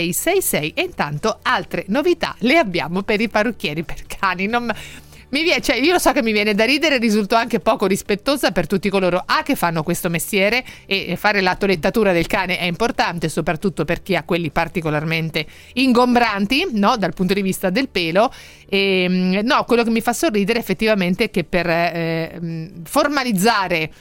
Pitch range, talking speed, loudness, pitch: 175-235 Hz, 180 wpm, -18 LUFS, 200 Hz